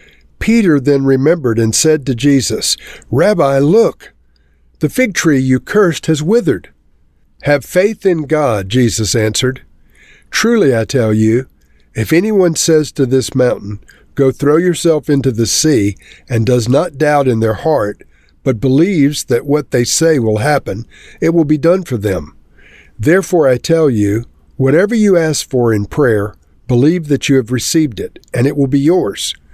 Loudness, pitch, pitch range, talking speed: -13 LUFS, 135 Hz, 115-155 Hz, 165 wpm